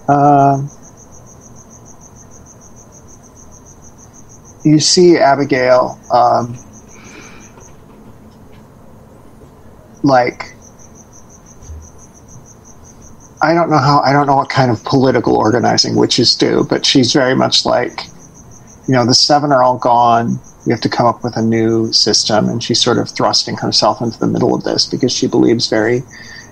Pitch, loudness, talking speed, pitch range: 125 Hz, -12 LUFS, 125 wpm, 115-140 Hz